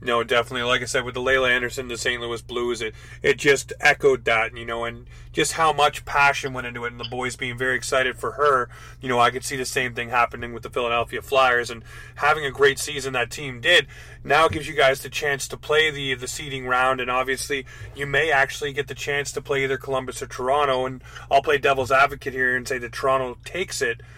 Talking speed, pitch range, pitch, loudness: 240 wpm, 120-140 Hz, 130 Hz, -22 LUFS